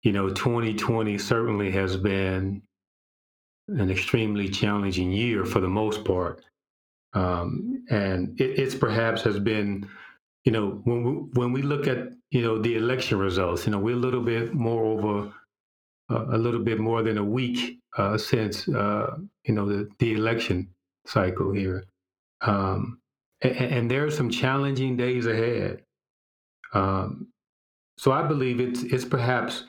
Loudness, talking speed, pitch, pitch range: -26 LUFS, 155 wpm, 115 Hz, 100-125 Hz